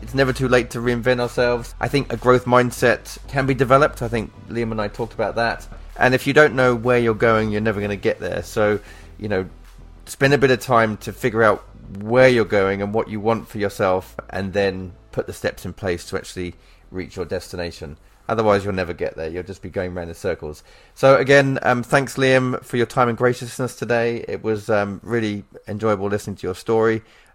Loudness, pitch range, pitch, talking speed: -20 LUFS, 100-125 Hz, 110 Hz, 220 wpm